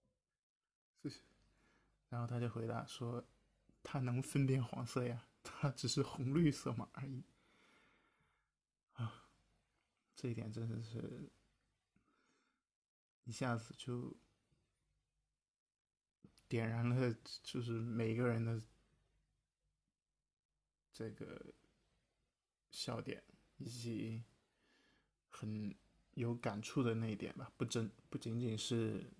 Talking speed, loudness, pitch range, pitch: 135 characters per minute, -43 LUFS, 115-125 Hz, 120 Hz